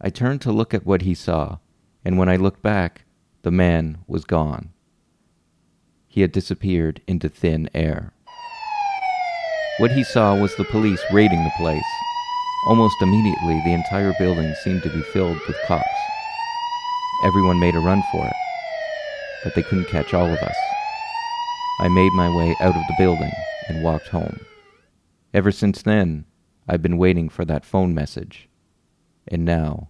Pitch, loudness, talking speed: 95 Hz, -21 LUFS, 160 wpm